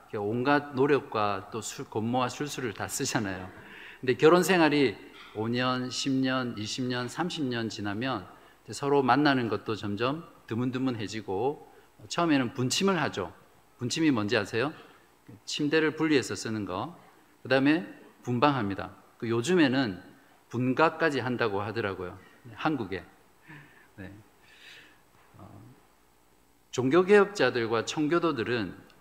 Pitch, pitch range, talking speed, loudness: 125 Hz, 110-145 Hz, 240 characters per minute, -28 LUFS